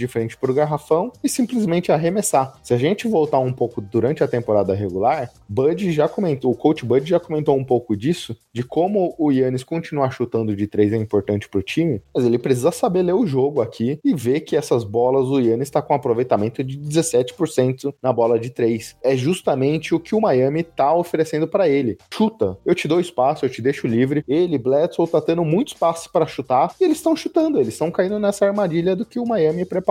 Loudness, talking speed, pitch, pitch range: -20 LUFS, 215 wpm, 150 Hz, 125-175 Hz